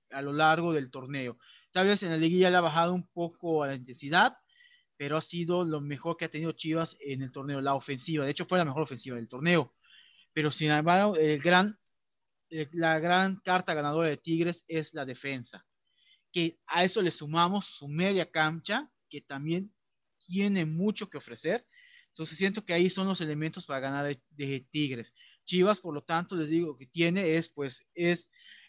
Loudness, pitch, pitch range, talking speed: -30 LUFS, 165 Hz, 145-180 Hz, 195 wpm